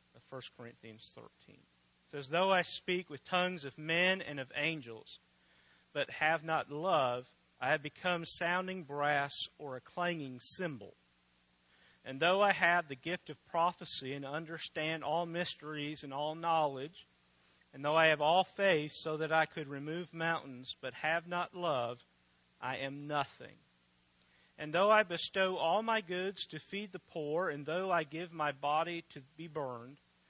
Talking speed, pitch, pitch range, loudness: 160 wpm, 150 Hz, 130-170 Hz, -35 LUFS